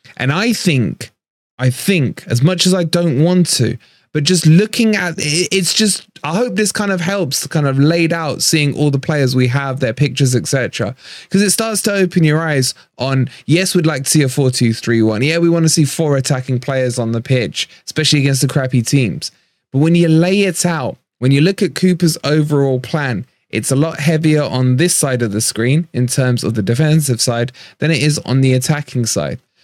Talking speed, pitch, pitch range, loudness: 215 wpm, 145 Hz, 130-170 Hz, -15 LUFS